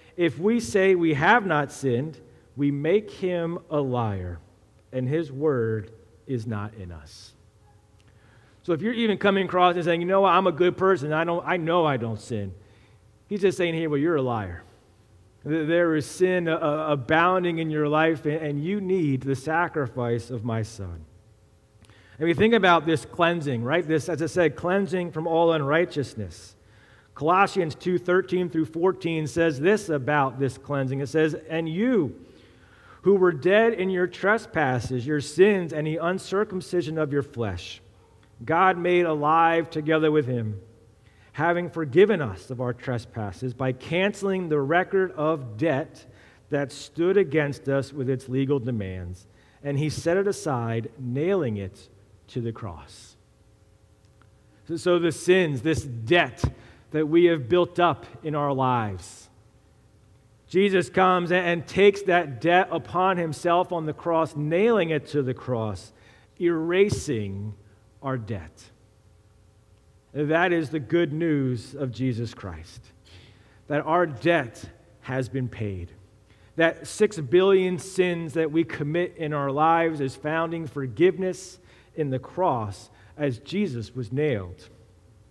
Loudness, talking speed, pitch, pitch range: -24 LUFS, 145 wpm, 145 Hz, 110-170 Hz